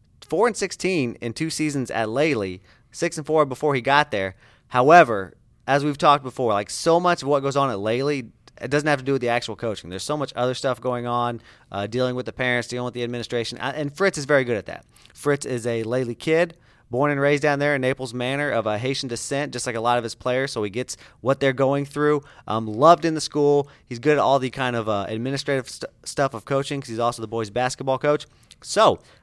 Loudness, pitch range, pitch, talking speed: -22 LUFS, 120-145 Hz, 130 Hz, 240 wpm